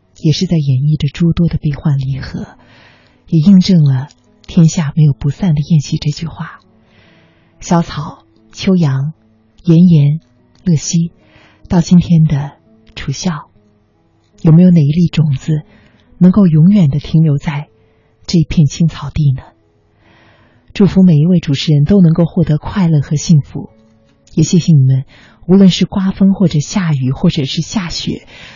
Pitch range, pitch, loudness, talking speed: 130-170 Hz, 155 Hz, -12 LUFS, 215 characters per minute